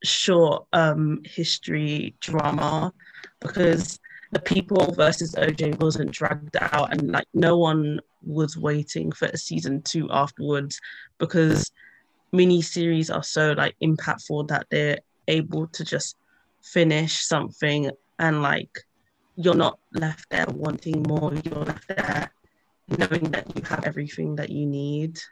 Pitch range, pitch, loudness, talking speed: 150-170 Hz, 155 Hz, -24 LUFS, 130 wpm